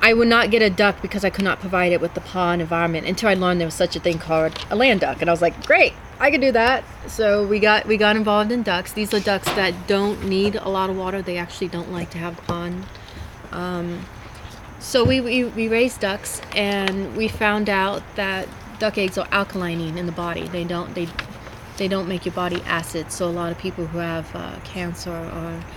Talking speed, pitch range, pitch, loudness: 235 wpm, 170-205 Hz, 185 Hz, -21 LUFS